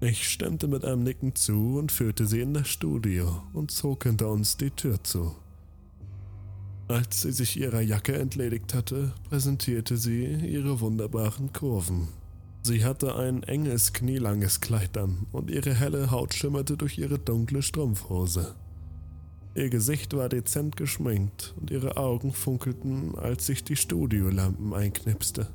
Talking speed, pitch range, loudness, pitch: 145 wpm, 100-135 Hz, -28 LUFS, 120 Hz